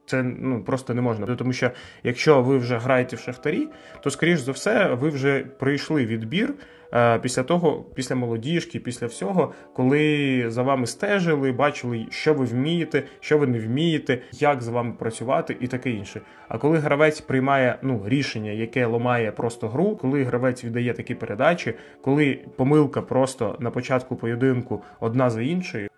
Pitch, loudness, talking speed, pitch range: 130 Hz, -23 LUFS, 160 wpm, 120-145 Hz